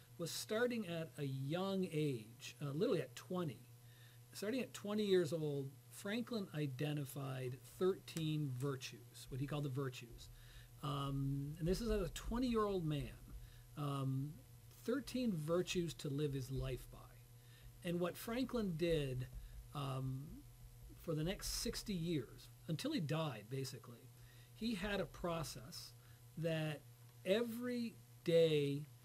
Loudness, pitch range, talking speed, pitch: -42 LUFS, 120-175 Hz, 130 wpm, 145 Hz